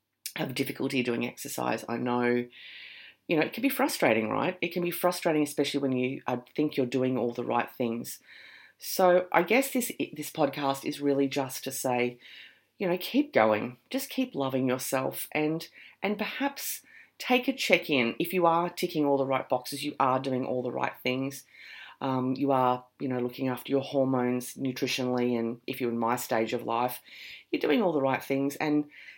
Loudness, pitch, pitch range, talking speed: -29 LUFS, 135 Hz, 125-165 Hz, 195 wpm